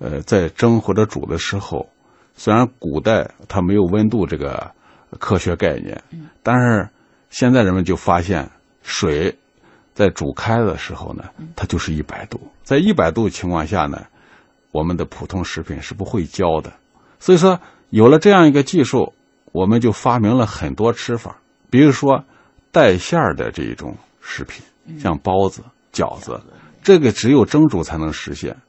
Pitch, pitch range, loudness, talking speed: 110 Hz, 90-125 Hz, -17 LUFS, 240 characters per minute